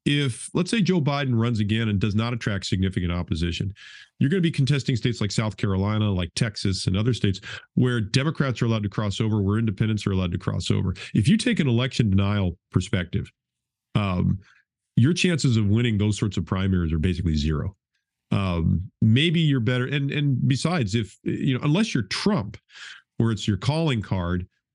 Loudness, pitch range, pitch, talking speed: -24 LUFS, 100-135 Hz, 110 Hz, 190 wpm